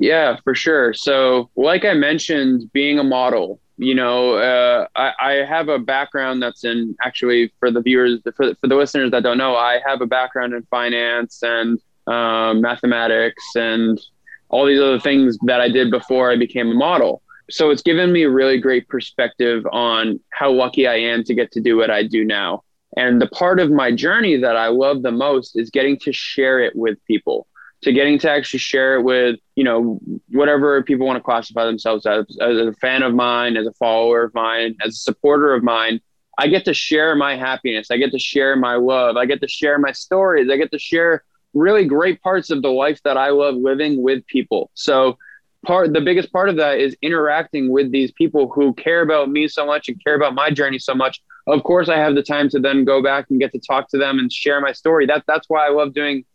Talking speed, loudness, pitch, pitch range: 225 wpm, -17 LUFS, 130 Hz, 120-145 Hz